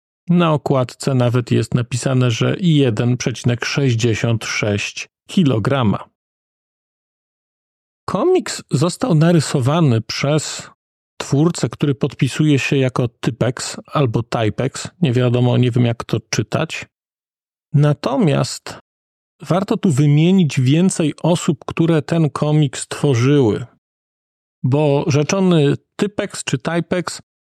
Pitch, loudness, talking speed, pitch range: 145 Hz, -17 LUFS, 90 wpm, 125-165 Hz